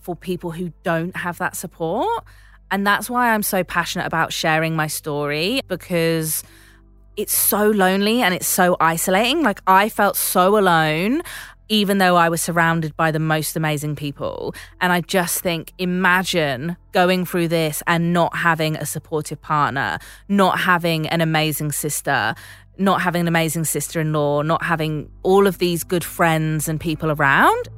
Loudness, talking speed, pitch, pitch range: -19 LUFS, 165 wpm, 170 Hz, 155-185 Hz